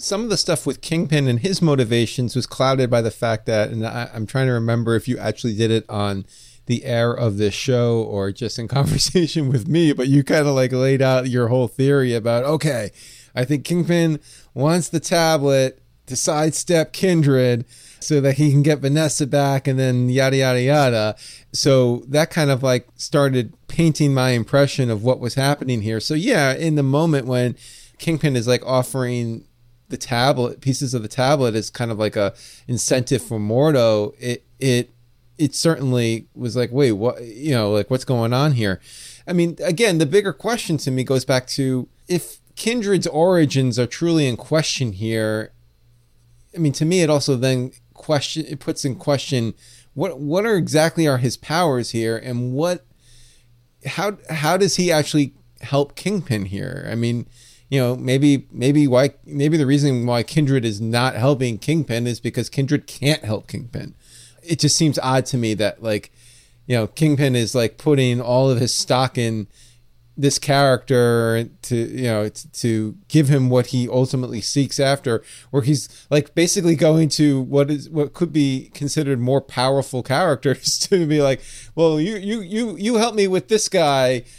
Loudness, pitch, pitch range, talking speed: -19 LUFS, 130 Hz, 120-150 Hz, 180 wpm